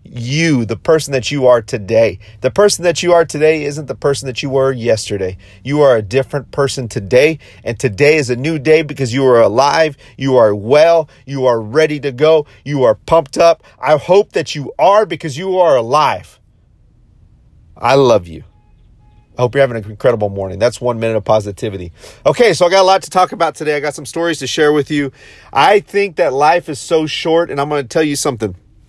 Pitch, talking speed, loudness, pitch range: 140 Hz, 215 wpm, -13 LUFS, 120-160 Hz